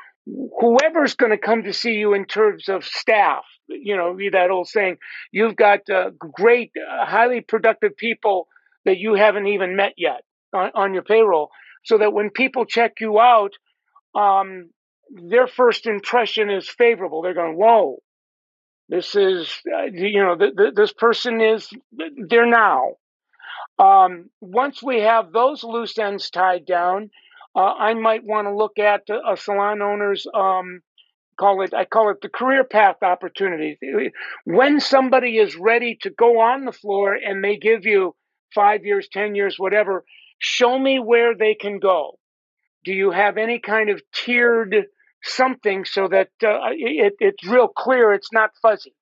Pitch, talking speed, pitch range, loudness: 215 Hz, 165 wpm, 200-245 Hz, -18 LUFS